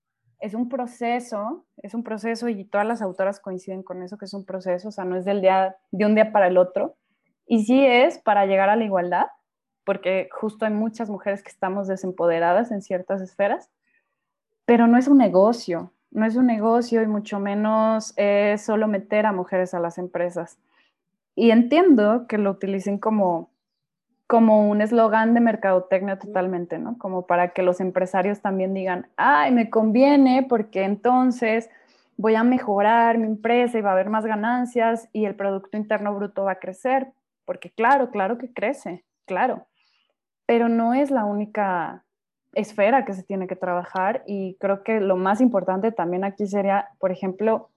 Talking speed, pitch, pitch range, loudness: 175 wpm, 205 Hz, 190-230 Hz, -21 LUFS